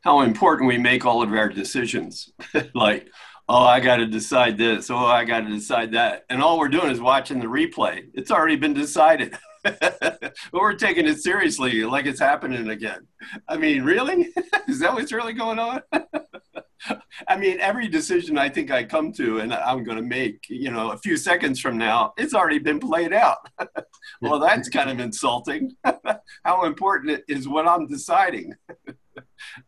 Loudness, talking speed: -21 LUFS, 175 wpm